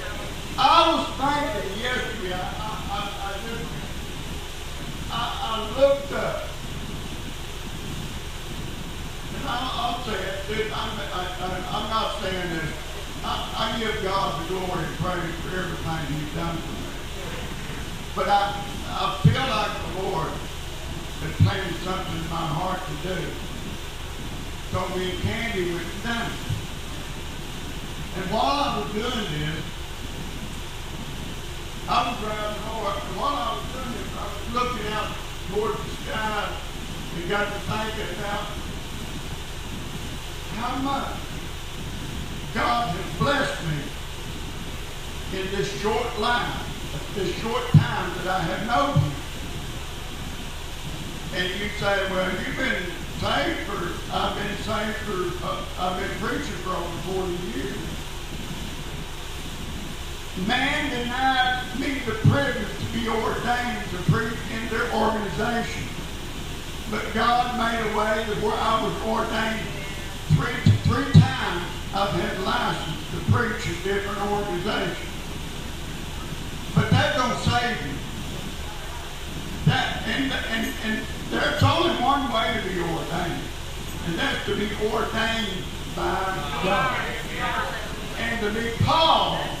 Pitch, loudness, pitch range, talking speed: 200 Hz, -26 LUFS, 170-225 Hz, 125 wpm